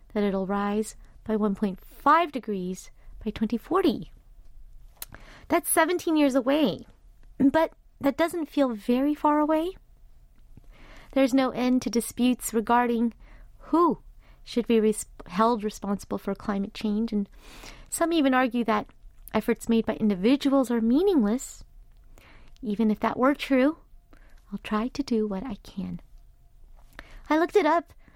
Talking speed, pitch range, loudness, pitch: 130 wpm, 215-285 Hz, -26 LUFS, 240 Hz